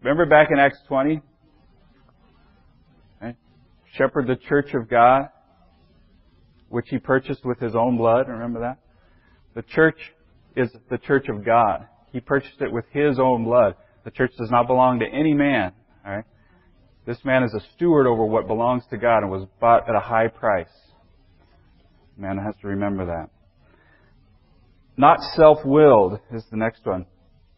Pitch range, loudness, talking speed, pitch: 100-130 Hz, -20 LUFS, 160 wpm, 115 Hz